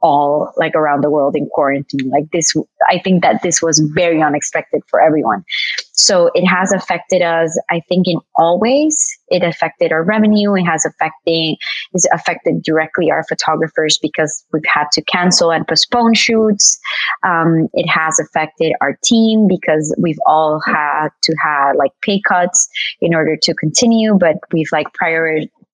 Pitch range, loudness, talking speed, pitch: 155-185 Hz, -13 LUFS, 165 wpm, 165 Hz